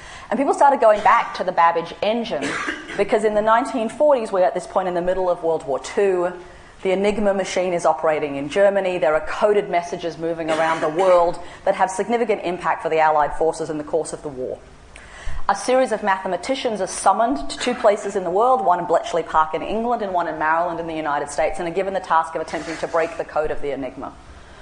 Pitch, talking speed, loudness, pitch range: 175 Hz, 225 wpm, -20 LUFS, 160-205 Hz